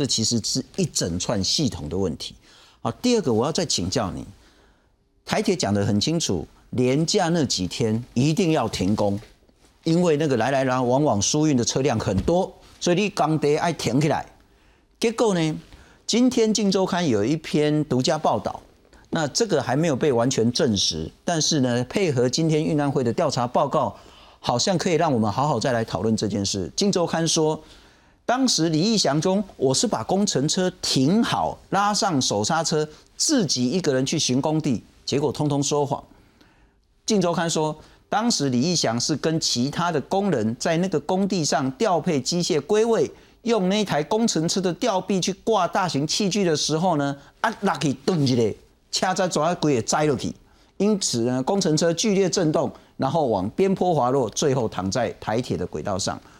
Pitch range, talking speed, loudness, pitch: 130-185 Hz, 265 characters per minute, -22 LUFS, 155 Hz